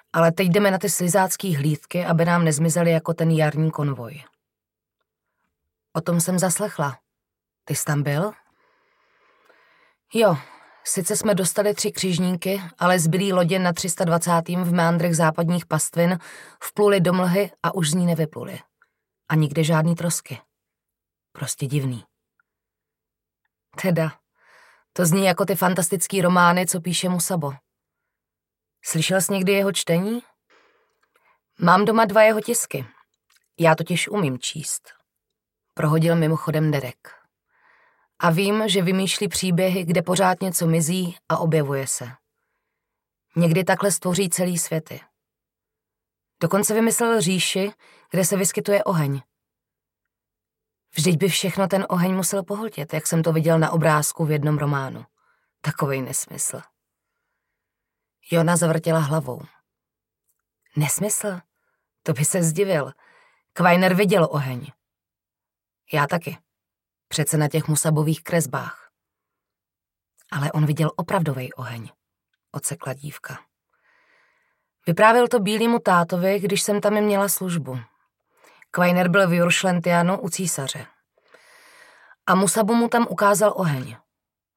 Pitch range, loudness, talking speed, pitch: 155-200 Hz, -21 LUFS, 120 wpm, 175 Hz